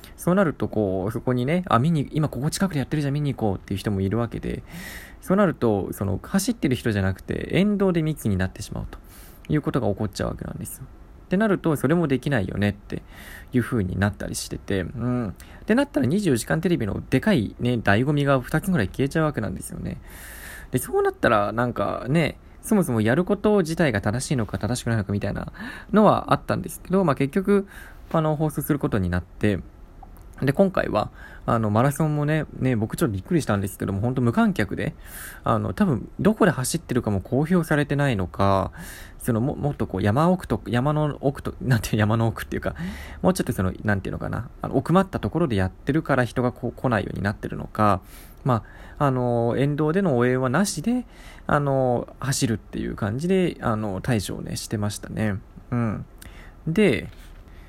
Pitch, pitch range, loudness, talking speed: 120 Hz, 100-155 Hz, -24 LUFS, 410 characters per minute